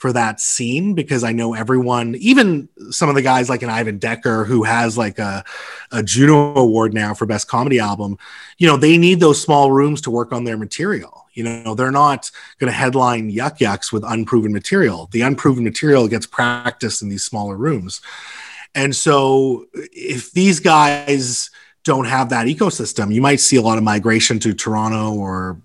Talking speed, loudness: 185 wpm, -16 LUFS